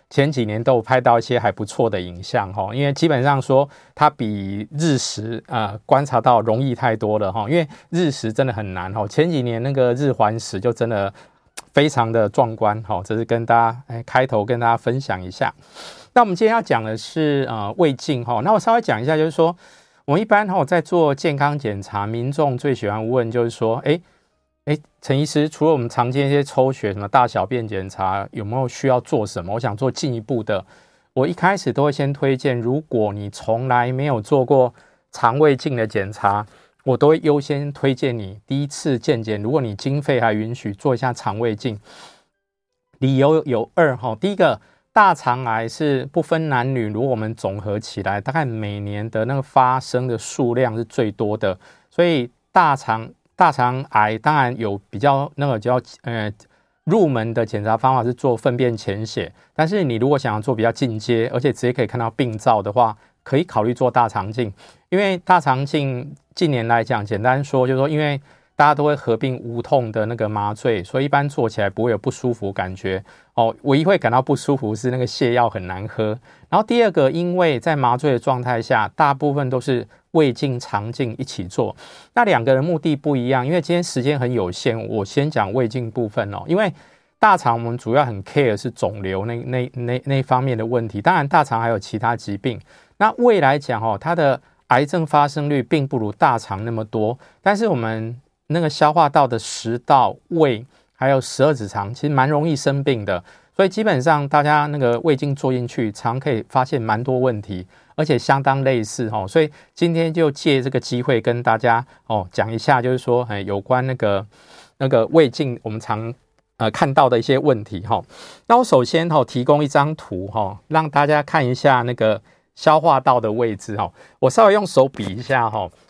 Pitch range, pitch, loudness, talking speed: 110-145 Hz, 125 Hz, -19 LUFS, 295 characters per minute